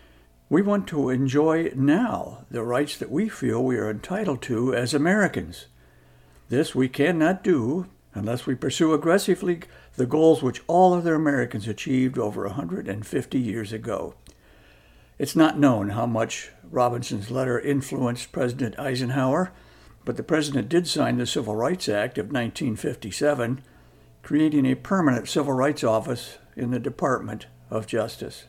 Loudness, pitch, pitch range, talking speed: -24 LUFS, 130 Hz, 115-150 Hz, 140 wpm